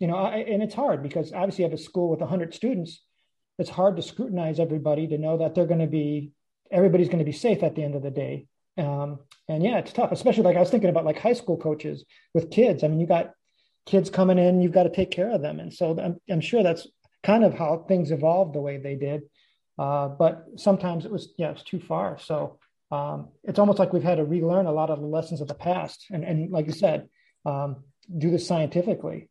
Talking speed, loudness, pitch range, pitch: 245 wpm, -25 LUFS, 155-185 Hz, 170 Hz